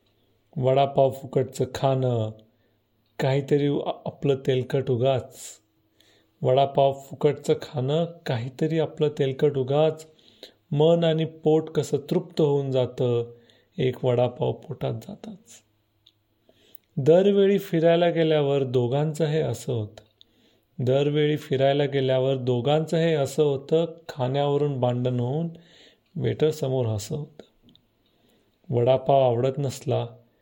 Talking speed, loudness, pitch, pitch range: 95 wpm, -24 LUFS, 135 Hz, 125-155 Hz